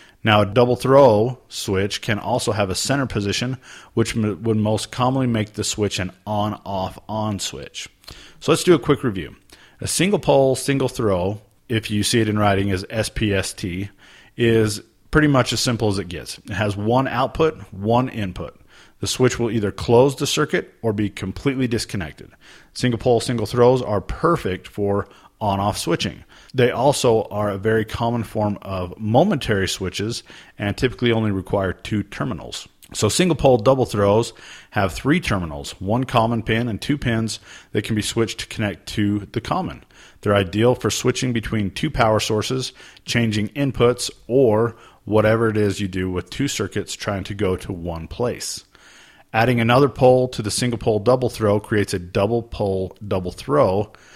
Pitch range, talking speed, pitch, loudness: 100-125 Hz, 175 wpm, 110 Hz, -20 LUFS